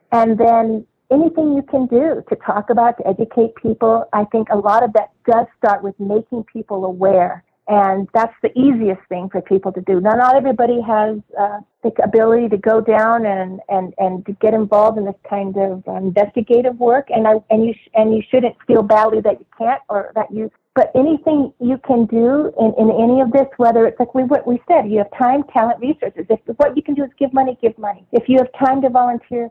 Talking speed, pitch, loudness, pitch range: 220 wpm, 225 Hz, -16 LUFS, 210-245 Hz